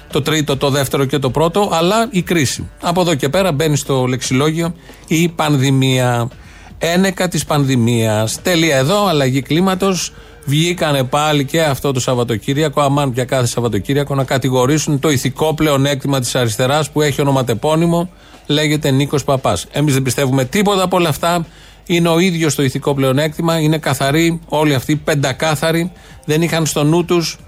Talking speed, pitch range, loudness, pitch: 155 wpm, 135-165 Hz, -15 LUFS, 150 Hz